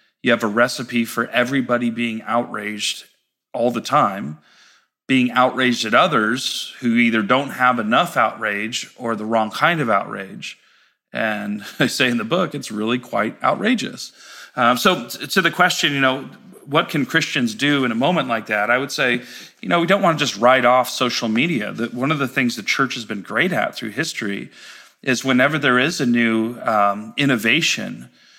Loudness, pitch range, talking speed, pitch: -19 LUFS, 115-135 Hz, 185 wpm, 120 Hz